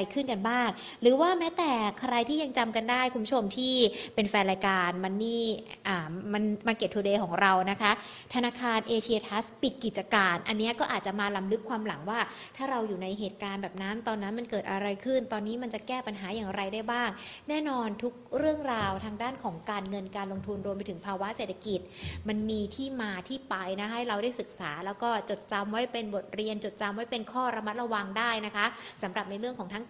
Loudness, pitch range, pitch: -31 LUFS, 200-240 Hz, 215 Hz